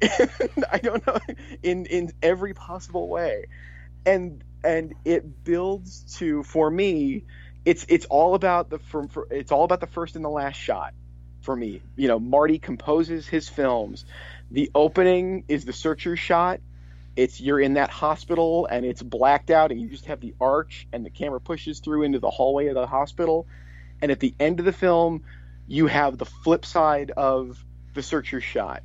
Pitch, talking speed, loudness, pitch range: 150 Hz, 180 wpm, -24 LUFS, 120-170 Hz